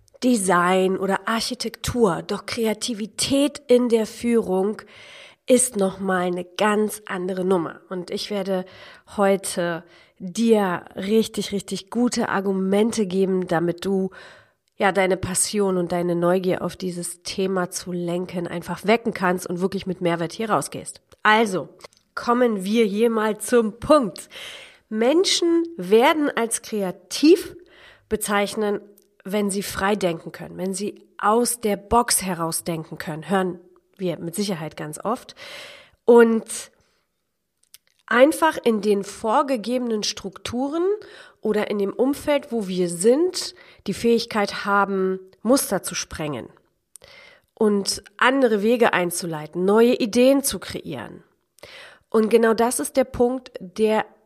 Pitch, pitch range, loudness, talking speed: 205 Hz, 185-235 Hz, -22 LUFS, 125 wpm